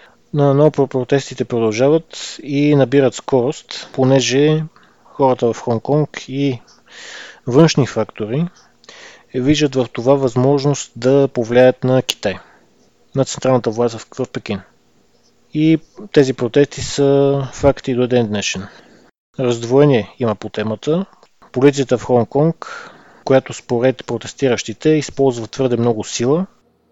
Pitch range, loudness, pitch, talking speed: 120-145 Hz, -16 LUFS, 130 Hz, 110 wpm